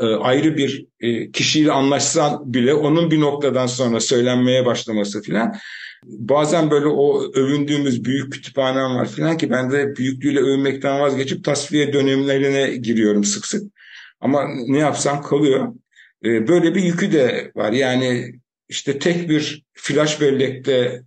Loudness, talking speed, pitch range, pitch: -18 LUFS, 130 wpm, 125-150 Hz, 135 Hz